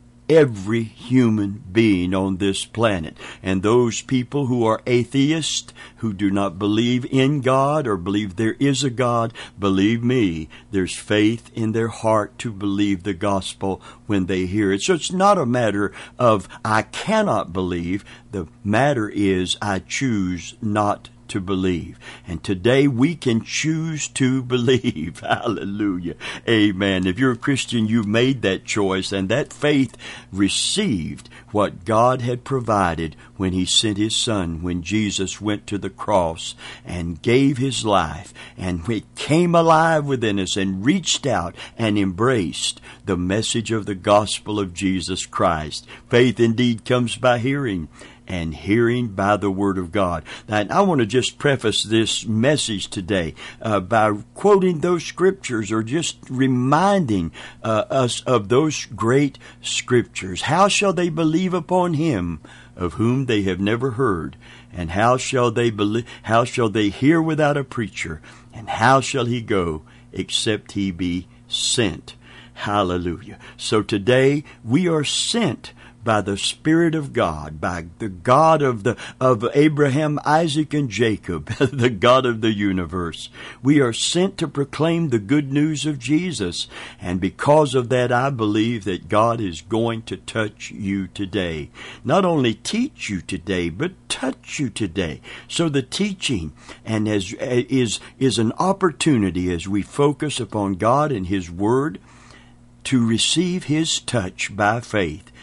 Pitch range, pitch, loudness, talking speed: 100-135 Hz, 115 Hz, -20 LUFS, 150 wpm